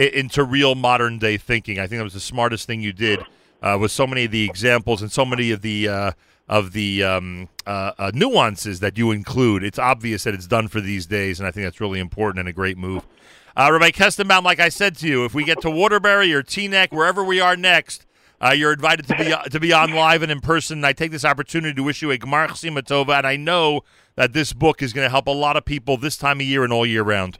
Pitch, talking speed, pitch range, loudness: 130 Hz, 255 wpm, 105-155 Hz, -18 LUFS